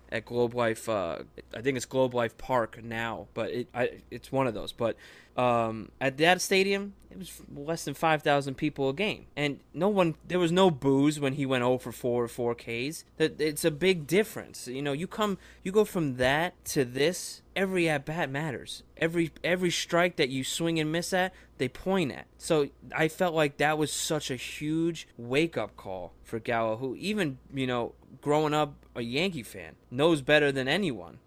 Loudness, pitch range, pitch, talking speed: -29 LUFS, 125-170 Hz, 145 Hz, 200 wpm